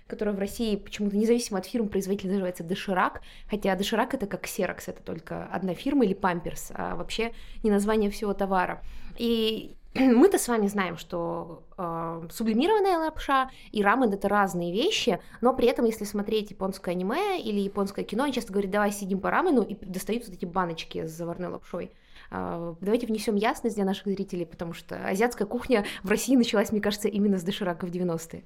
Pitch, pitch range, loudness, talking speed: 205 Hz, 185-230 Hz, -27 LUFS, 185 wpm